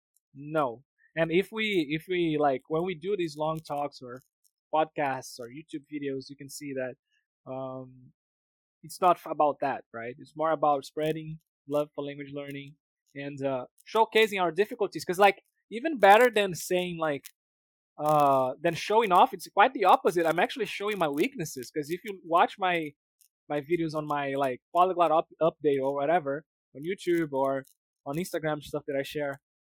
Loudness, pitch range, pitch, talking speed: -28 LUFS, 140-180 Hz, 155 Hz, 170 wpm